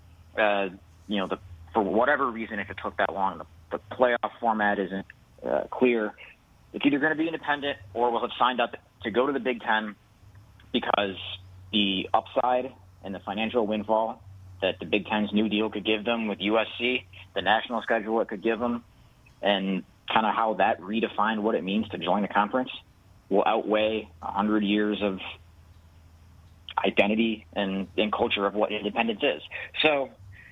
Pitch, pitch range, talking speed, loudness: 105 Hz, 95-115 Hz, 175 wpm, -27 LUFS